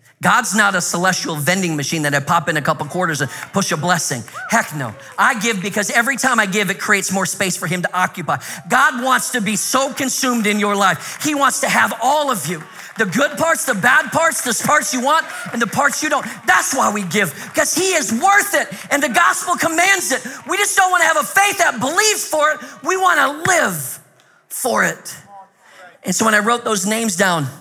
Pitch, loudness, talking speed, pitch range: 230 Hz, -16 LUFS, 230 wpm, 190-300 Hz